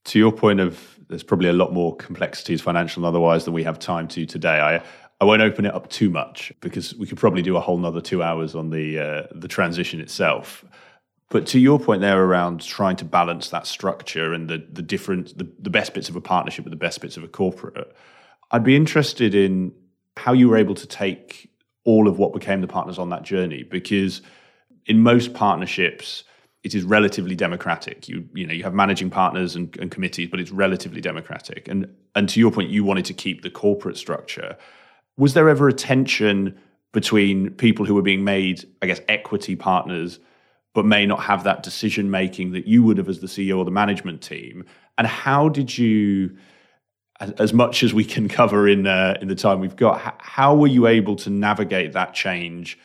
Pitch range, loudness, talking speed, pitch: 90-110 Hz, -20 LUFS, 210 wpm, 100 Hz